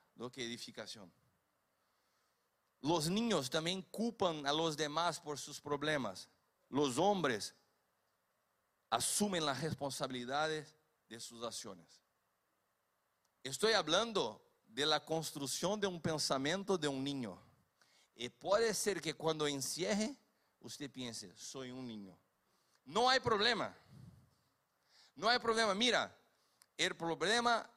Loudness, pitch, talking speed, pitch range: -37 LUFS, 155 Hz, 110 wpm, 140-195 Hz